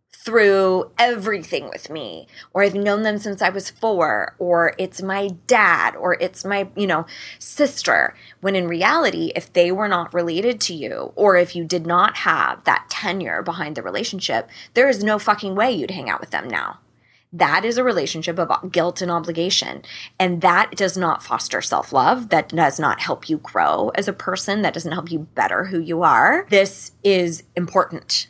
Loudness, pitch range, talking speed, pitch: -19 LUFS, 175-205 Hz, 185 wpm, 185 Hz